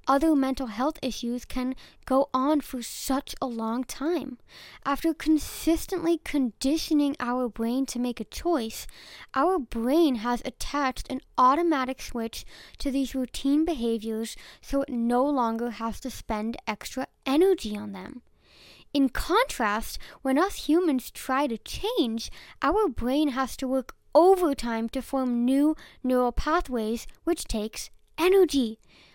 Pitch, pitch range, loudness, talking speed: 265 Hz, 245-300 Hz, -27 LUFS, 135 wpm